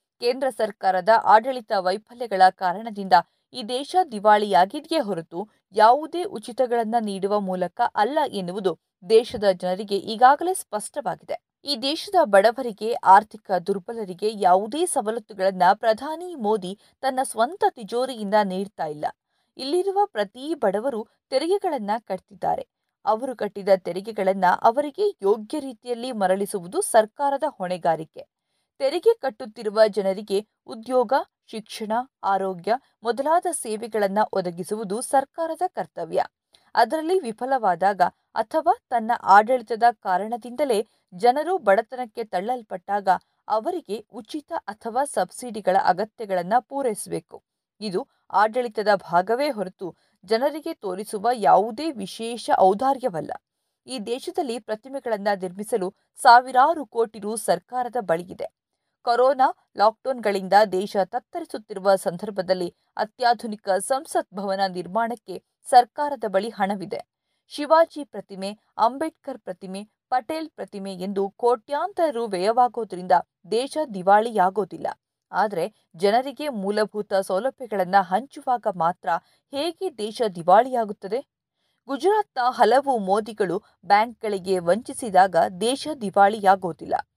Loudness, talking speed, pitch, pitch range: -23 LUFS, 90 wpm, 225 Hz, 195-265 Hz